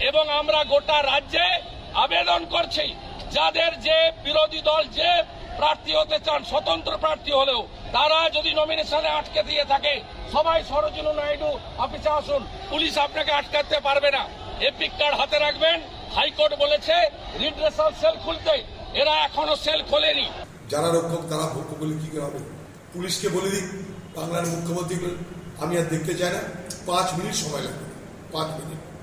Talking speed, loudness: 120 wpm, -23 LUFS